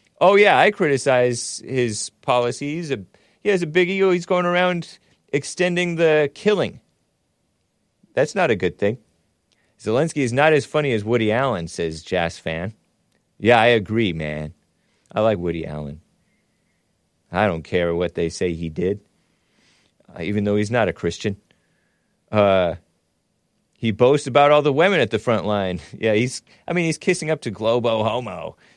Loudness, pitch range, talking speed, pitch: -20 LUFS, 95-150 Hz, 160 wpm, 115 Hz